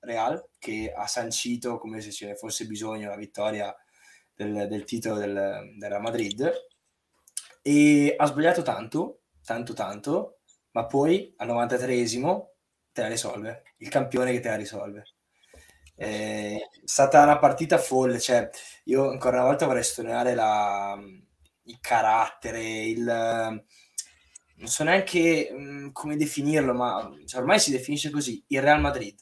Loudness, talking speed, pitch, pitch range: -25 LUFS, 140 wpm, 120 Hz, 105-145 Hz